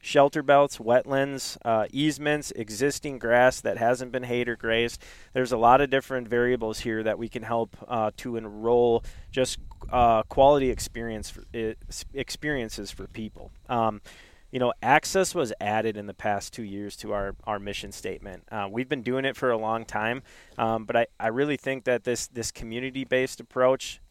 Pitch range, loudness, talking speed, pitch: 110-130 Hz, -26 LUFS, 180 wpm, 115 Hz